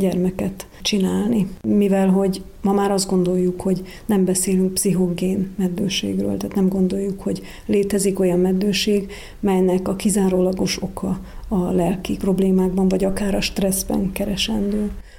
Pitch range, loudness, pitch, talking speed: 185-200 Hz, -20 LUFS, 190 Hz, 125 wpm